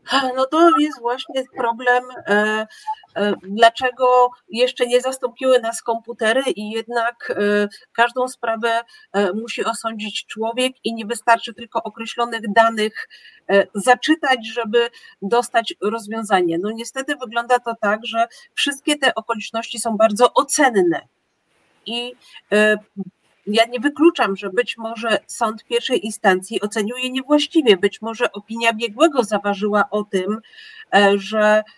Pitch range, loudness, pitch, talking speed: 215-255 Hz, -19 LUFS, 230 Hz, 115 wpm